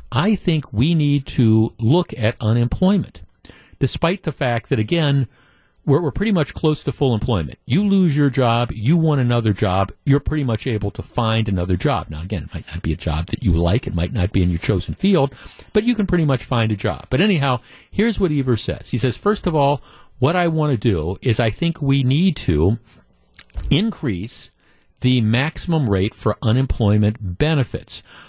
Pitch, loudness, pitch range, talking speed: 125 Hz, -19 LUFS, 105-150 Hz, 195 wpm